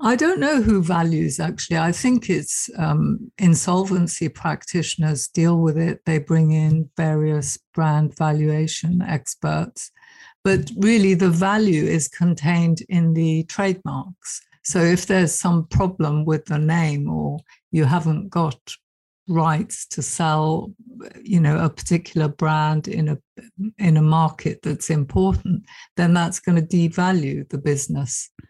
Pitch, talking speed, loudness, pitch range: 165 Hz, 135 wpm, -20 LUFS, 155-185 Hz